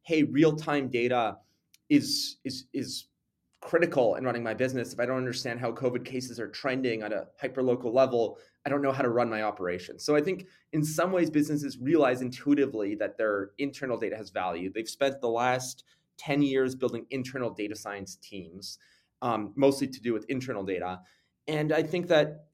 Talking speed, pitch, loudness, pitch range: 185 wpm, 130 Hz, -29 LUFS, 115-145 Hz